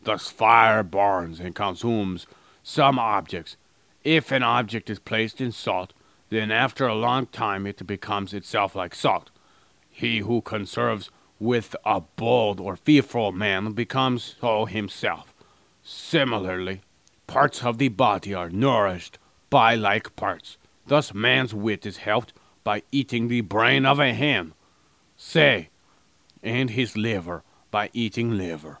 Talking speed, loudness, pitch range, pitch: 135 wpm, -23 LUFS, 100-120 Hz, 110 Hz